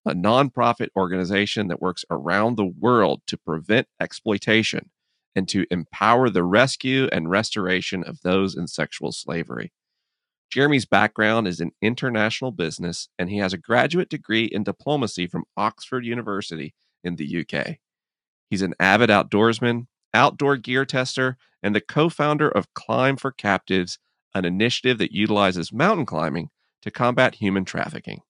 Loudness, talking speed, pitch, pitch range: -22 LUFS, 145 wpm, 110 Hz, 95-130 Hz